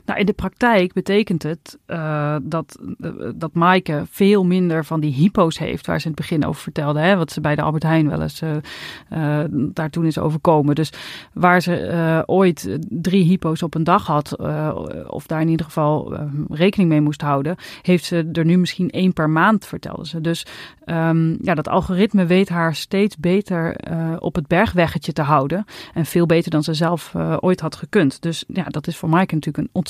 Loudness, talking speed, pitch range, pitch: -19 LUFS, 210 wpm, 155-180 Hz, 165 Hz